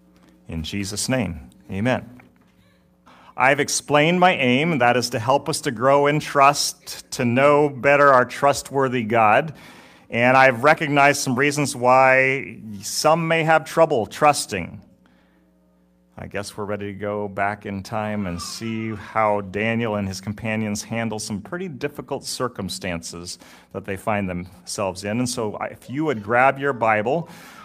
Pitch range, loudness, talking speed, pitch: 100-140 Hz, -20 LUFS, 150 wpm, 115 Hz